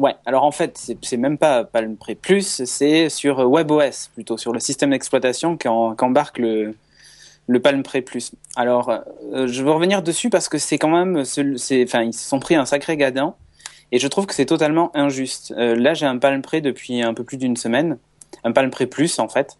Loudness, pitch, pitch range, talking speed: -19 LUFS, 135 Hz, 120-150 Hz, 220 wpm